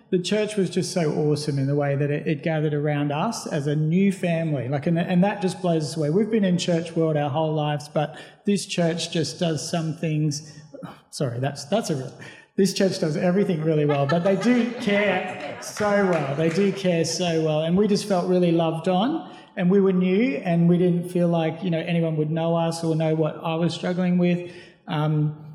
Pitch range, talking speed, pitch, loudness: 155-185 Hz, 215 wpm, 170 Hz, -23 LUFS